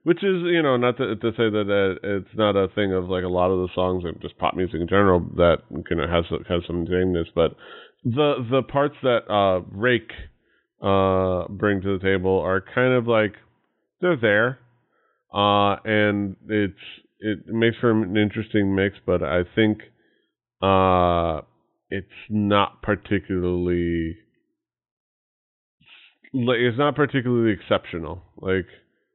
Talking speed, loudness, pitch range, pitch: 155 wpm, -22 LUFS, 90-115 Hz, 100 Hz